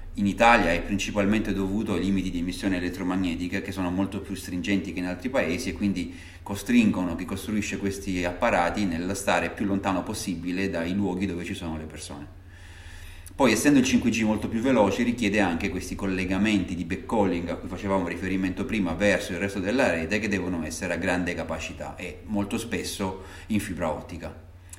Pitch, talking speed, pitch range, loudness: 95 Hz, 175 wpm, 90-100 Hz, -26 LUFS